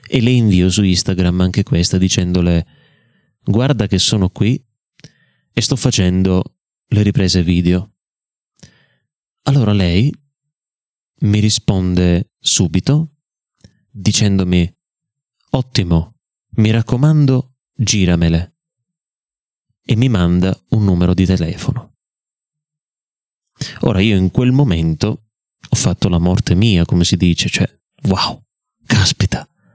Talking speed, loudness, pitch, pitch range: 105 wpm, -15 LUFS, 105 Hz, 90-125 Hz